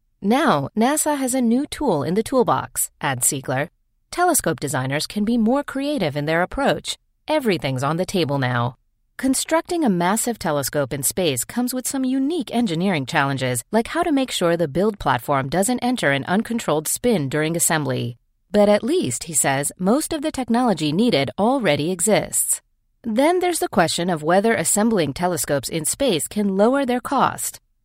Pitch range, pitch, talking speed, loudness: 155-255 Hz, 205 Hz, 170 wpm, -20 LUFS